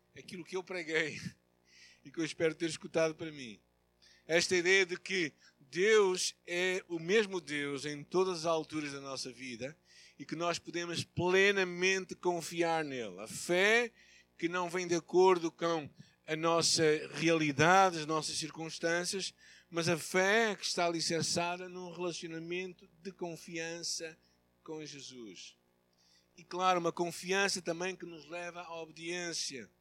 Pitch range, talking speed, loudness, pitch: 155-180 Hz, 145 wpm, -33 LUFS, 170 Hz